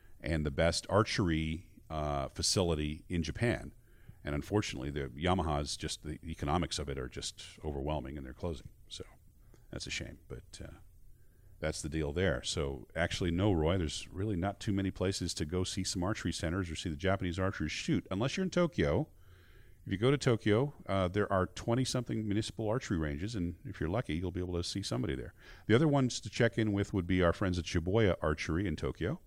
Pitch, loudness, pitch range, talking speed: 90 Hz, -34 LUFS, 80-105 Hz, 200 wpm